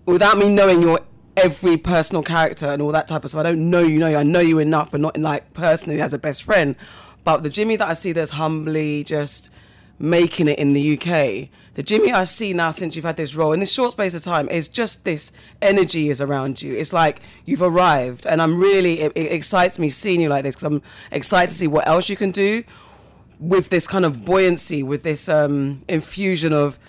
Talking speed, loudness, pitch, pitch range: 230 wpm, -19 LUFS, 160 Hz, 150-180 Hz